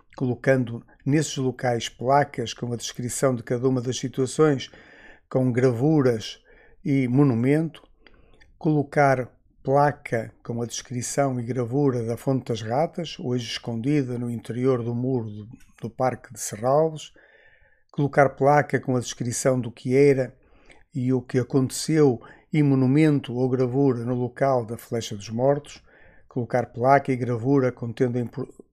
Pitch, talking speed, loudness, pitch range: 130 Hz, 140 wpm, -24 LUFS, 120-140 Hz